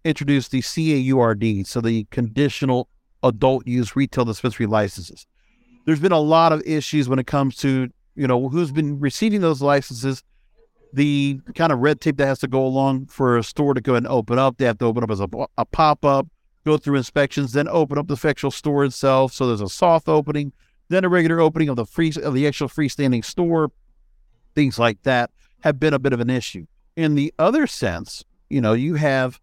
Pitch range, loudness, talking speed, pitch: 125-155 Hz, -20 LUFS, 205 wpm, 140 Hz